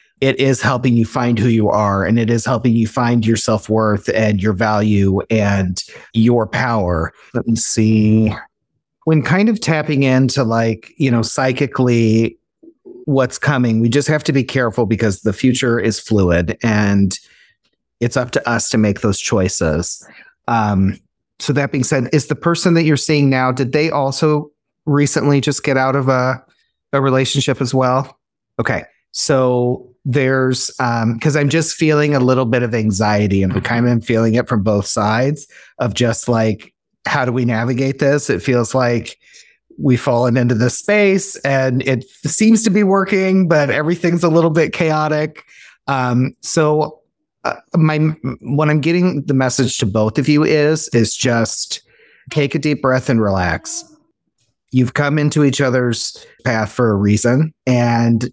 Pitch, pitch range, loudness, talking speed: 130 Hz, 115-150 Hz, -16 LUFS, 170 wpm